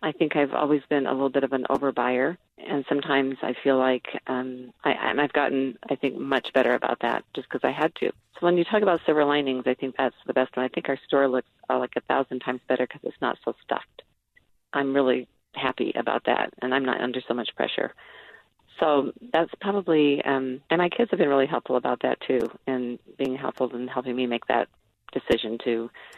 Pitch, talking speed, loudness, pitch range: 135 Hz, 225 wpm, -26 LUFS, 125-145 Hz